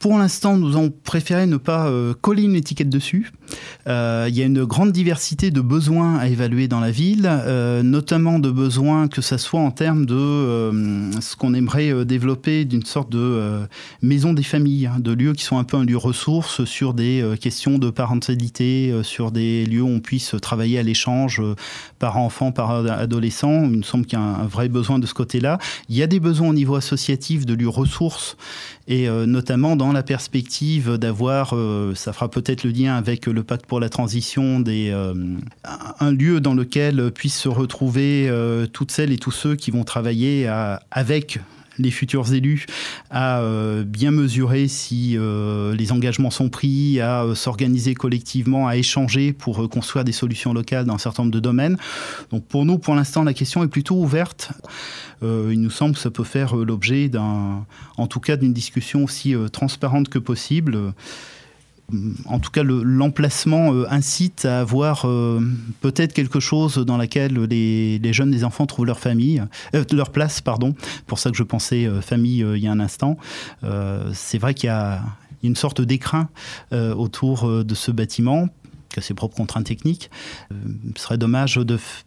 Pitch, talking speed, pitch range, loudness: 125 Hz, 190 wpm, 115-140 Hz, -20 LUFS